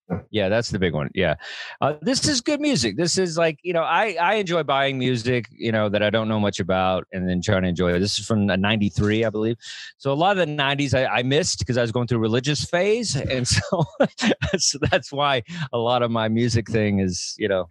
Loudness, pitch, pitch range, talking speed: -22 LUFS, 120 Hz, 105-155 Hz, 245 wpm